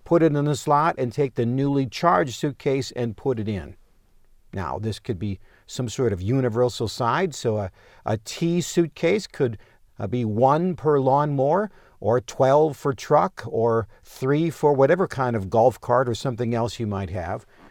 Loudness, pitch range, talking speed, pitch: -23 LUFS, 115-145 Hz, 175 wpm, 130 Hz